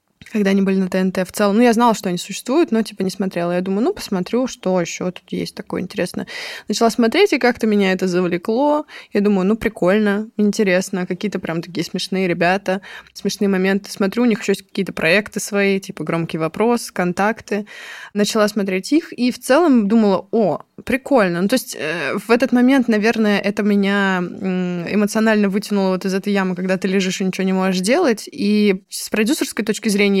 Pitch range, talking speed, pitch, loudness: 190-225 Hz, 190 wpm, 200 Hz, -18 LUFS